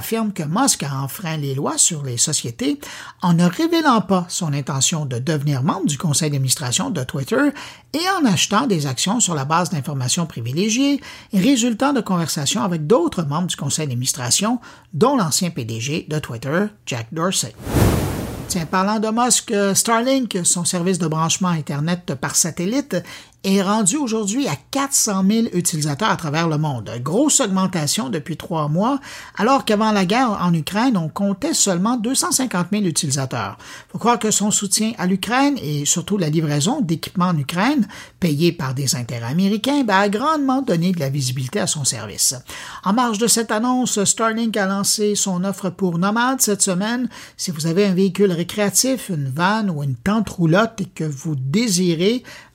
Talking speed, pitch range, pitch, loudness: 170 wpm, 155-220 Hz, 185 Hz, -19 LUFS